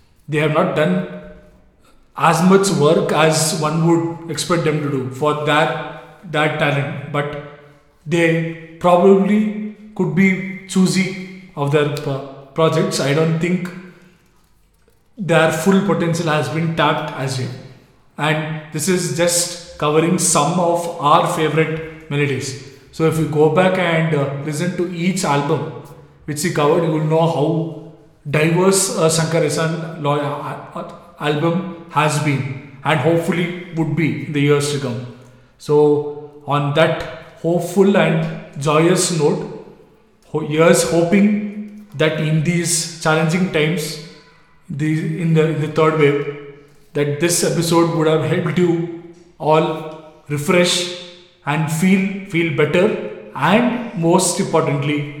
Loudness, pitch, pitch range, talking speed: -17 LUFS, 160 Hz, 150-175 Hz, 130 wpm